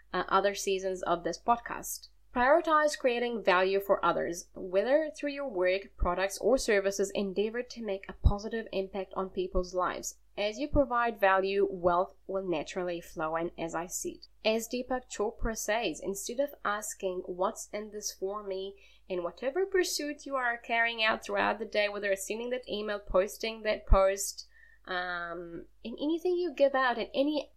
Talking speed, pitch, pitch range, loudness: 170 wpm, 205 Hz, 190-250 Hz, -31 LUFS